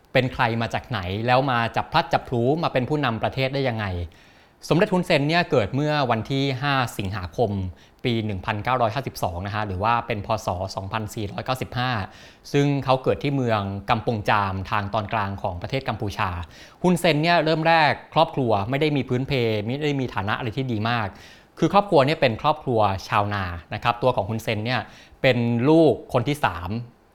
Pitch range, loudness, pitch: 105-135 Hz, -23 LUFS, 120 Hz